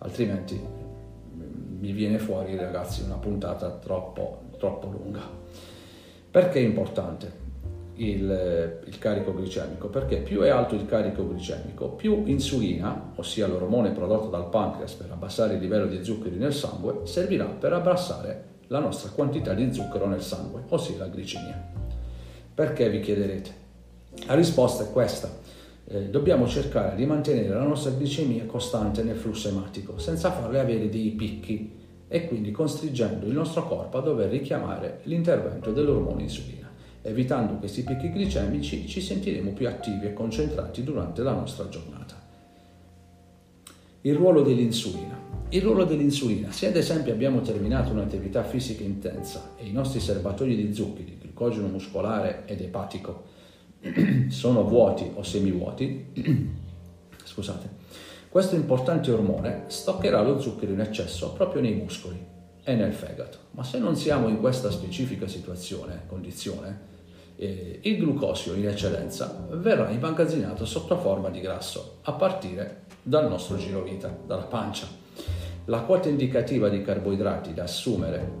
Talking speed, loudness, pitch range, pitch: 140 wpm, -27 LUFS, 90-125 Hz, 100 Hz